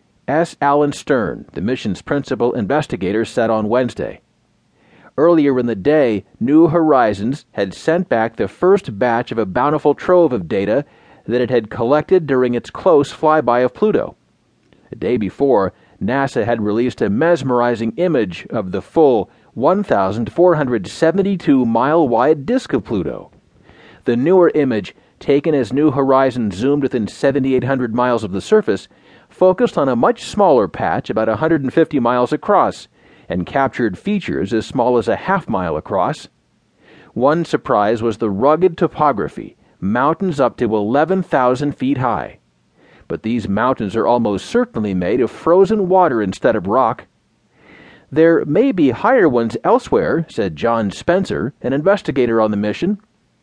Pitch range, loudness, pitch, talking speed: 115-165 Hz, -16 LUFS, 135 Hz, 145 wpm